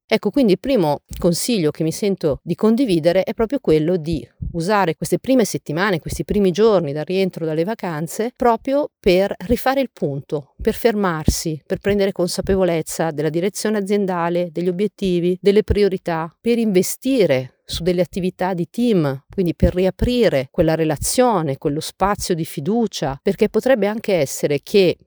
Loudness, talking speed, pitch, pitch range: -19 LUFS, 150 wpm, 185 Hz, 165-210 Hz